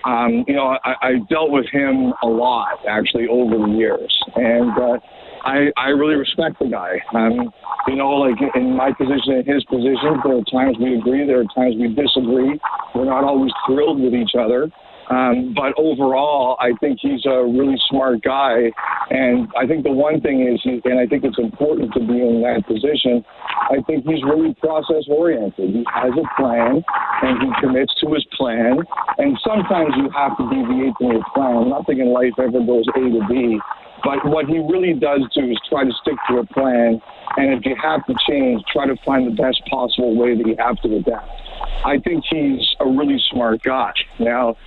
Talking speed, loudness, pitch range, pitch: 200 wpm, -17 LUFS, 120-145 Hz, 130 Hz